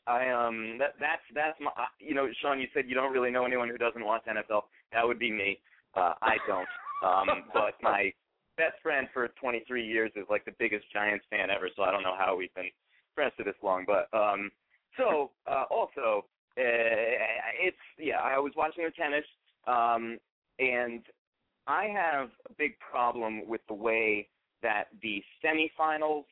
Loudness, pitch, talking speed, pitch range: -31 LUFS, 115 Hz, 180 wpm, 105-130 Hz